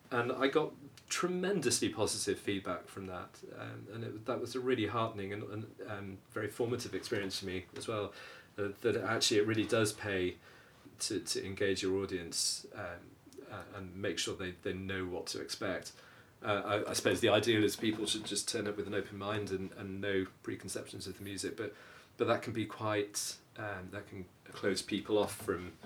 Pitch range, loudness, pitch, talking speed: 95-110 Hz, -36 LUFS, 100 Hz, 200 wpm